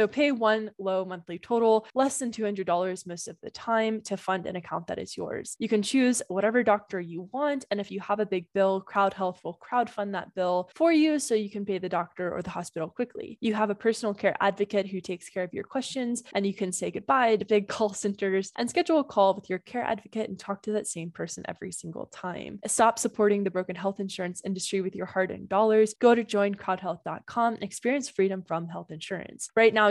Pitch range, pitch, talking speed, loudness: 190-225 Hz, 205 Hz, 225 wpm, -28 LUFS